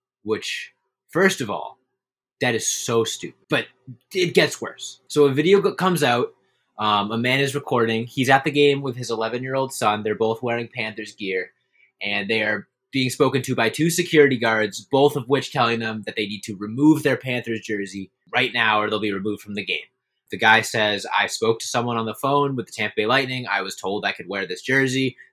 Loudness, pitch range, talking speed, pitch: -21 LUFS, 110-140 Hz, 220 wpm, 120 Hz